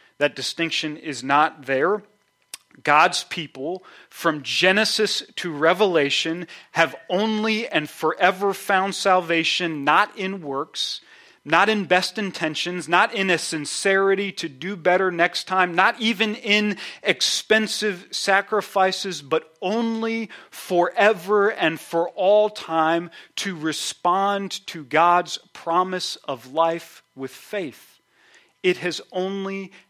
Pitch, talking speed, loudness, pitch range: 180 Hz, 115 wpm, -21 LUFS, 165-200 Hz